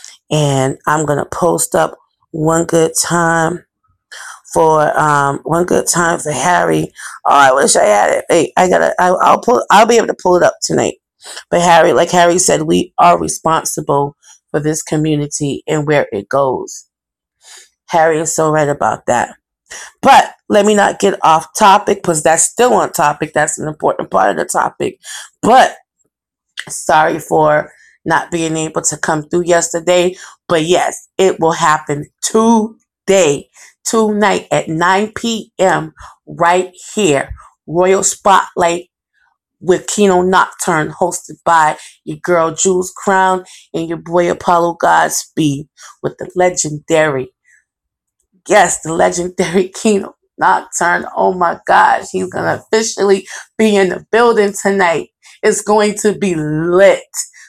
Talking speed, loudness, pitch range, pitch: 145 wpm, -13 LUFS, 155-195 Hz, 170 Hz